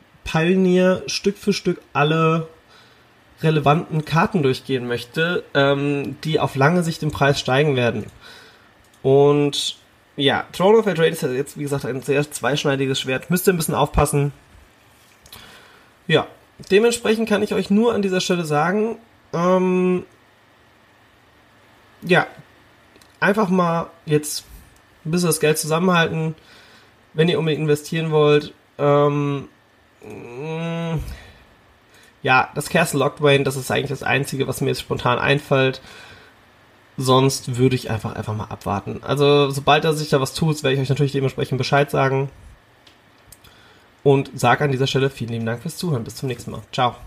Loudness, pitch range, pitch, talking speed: -20 LUFS, 135-165 Hz, 145 Hz, 145 wpm